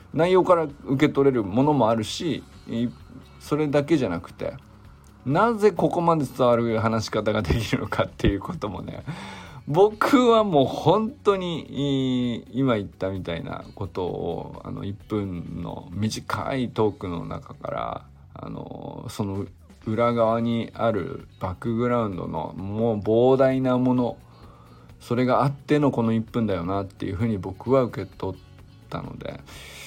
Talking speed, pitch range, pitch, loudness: 280 characters per minute, 100-140 Hz, 120 Hz, -24 LUFS